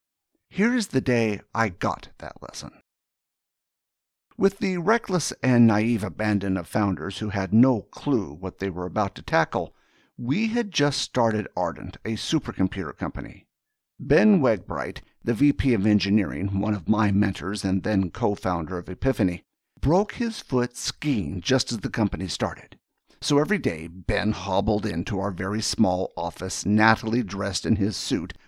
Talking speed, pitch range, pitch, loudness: 155 wpm, 95-130 Hz, 105 Hz, -25 LUFS